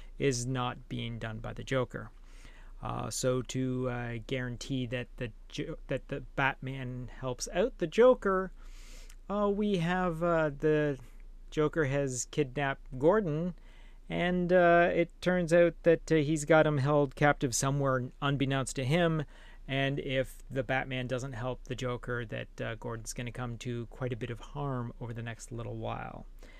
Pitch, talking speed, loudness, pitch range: 135 Hz, 160 wpm, -31 LUFS, 125-155 Hz